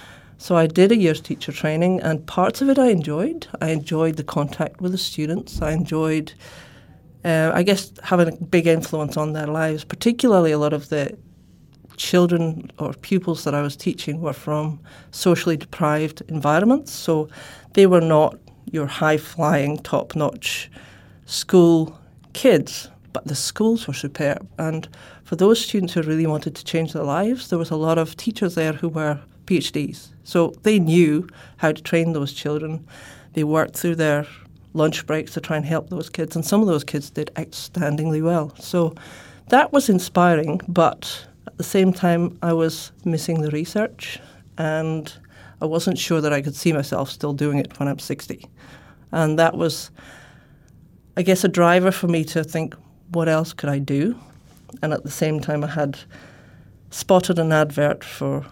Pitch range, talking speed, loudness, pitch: 150-175 Hz, 175 wpm, -21 LUFS, 160 Hz